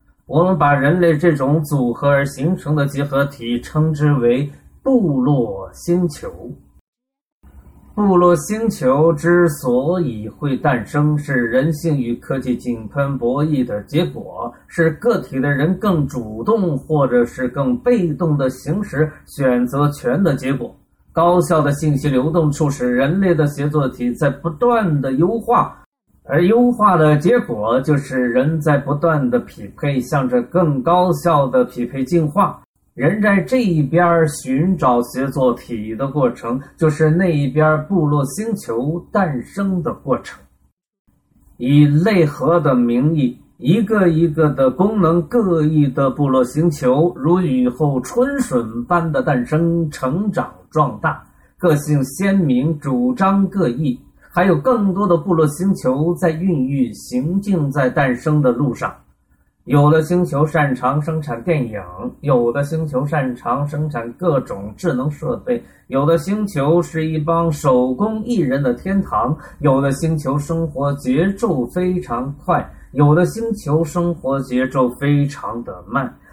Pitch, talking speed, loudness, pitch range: 150 Hz, 210 characters per minute, -17 LUFS, 130-175 Hz